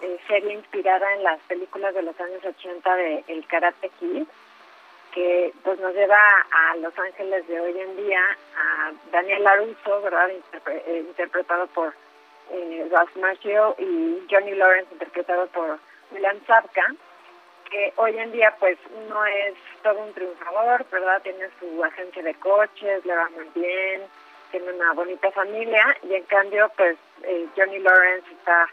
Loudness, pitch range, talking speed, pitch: -22 LUFS, 175-200 Hz, 150 wpm, 185 Hz